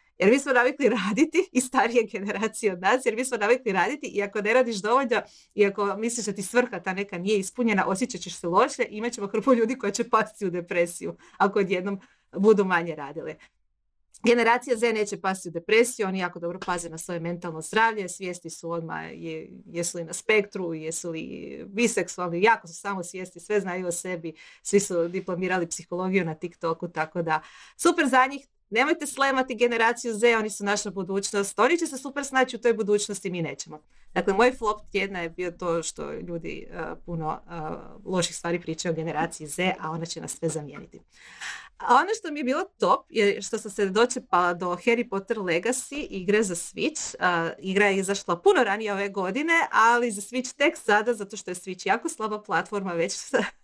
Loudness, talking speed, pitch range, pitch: -25 LUFS, 195 wpm, 175-235 Hz, 200 Hz